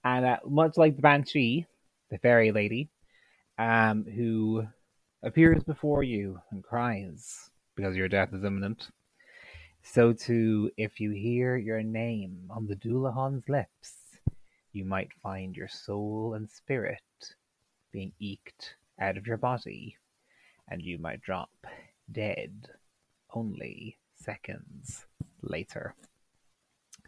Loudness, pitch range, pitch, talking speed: -29 LUFS, 100-125 Hz, 110 Hz, 115 wpm